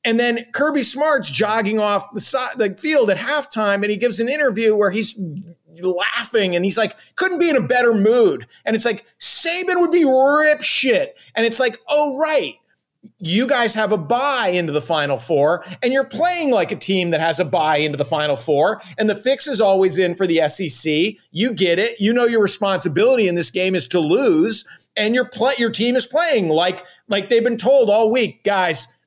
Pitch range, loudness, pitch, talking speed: 185-270 Hz, -17 LUFS, 220 Hz, 210 wpm